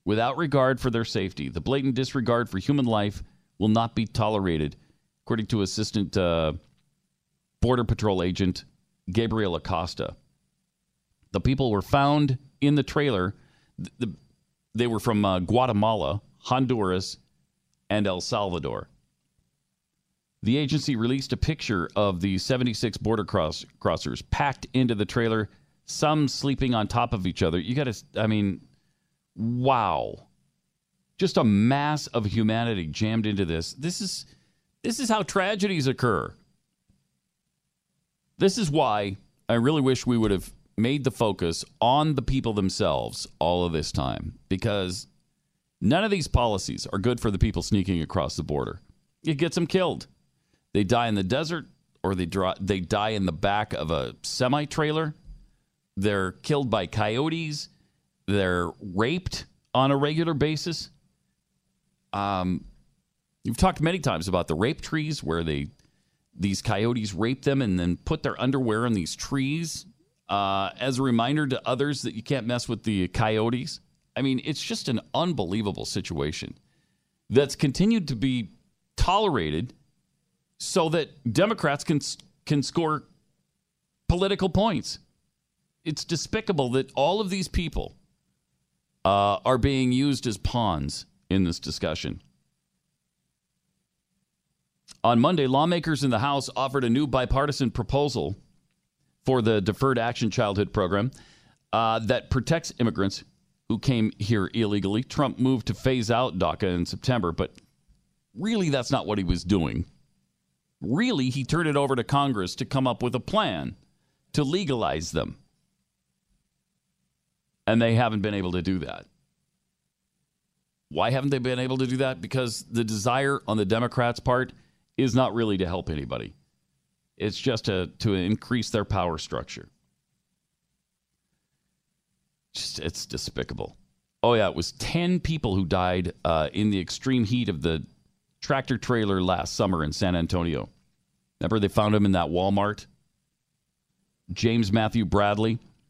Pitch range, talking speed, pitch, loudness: 100-135 Hz, 145 wpm, 115 Hz, -26 LUFS